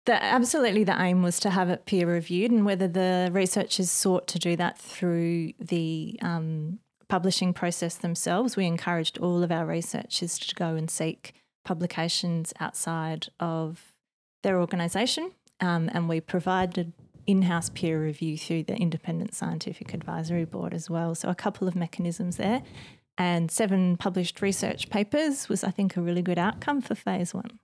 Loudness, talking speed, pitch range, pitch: -27 LUFS, 165 wpm, 170-195 Hz, 180 Hz